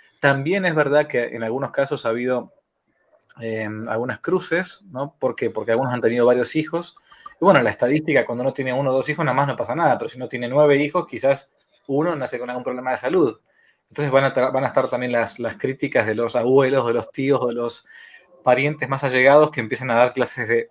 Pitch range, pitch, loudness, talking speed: 120-145 Hz, 130 Hz, -20 LUFS, 230 wpm